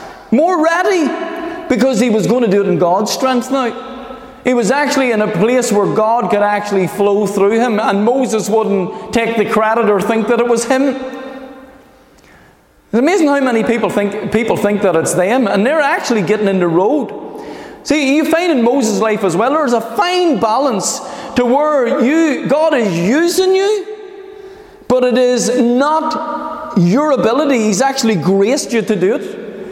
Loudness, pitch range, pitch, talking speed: -13 LUFS, 215-285 Hz, 245 Hz, 180 wpm